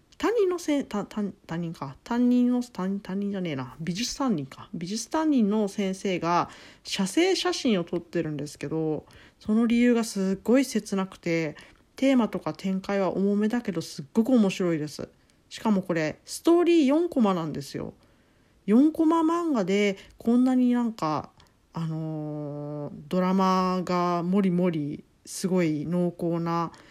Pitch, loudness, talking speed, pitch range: 195 Hz, -26 LUFS, 290 characters per minute, 170-235 Hz